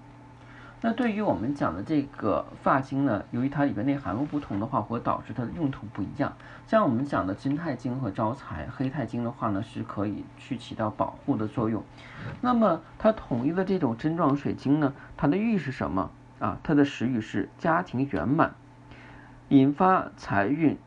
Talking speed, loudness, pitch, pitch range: 275 characters per minute, -28 LUFS, 135 Hz, 110-145 Hz